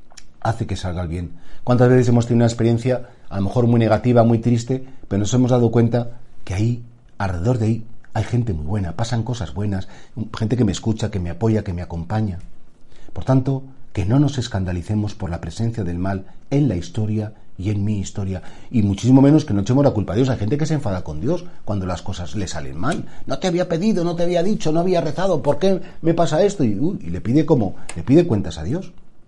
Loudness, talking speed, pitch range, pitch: -20 LUFS, 230 wpm, 100-130 Hz, 115 Hz